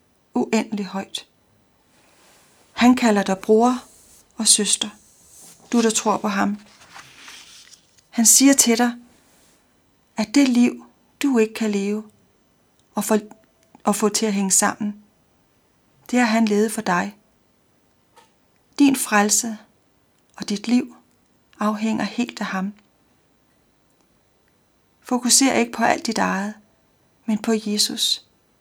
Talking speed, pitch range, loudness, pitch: 115 wpm, 210-240 Hz, -19 LUFS, 220 Hz